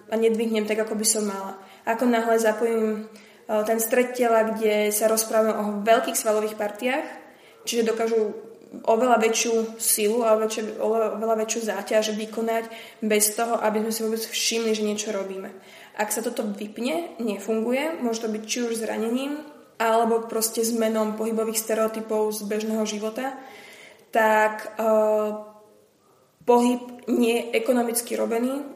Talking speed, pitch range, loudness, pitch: 140 wpm, 215-230 Hz, -24 LUFS, 225 Hz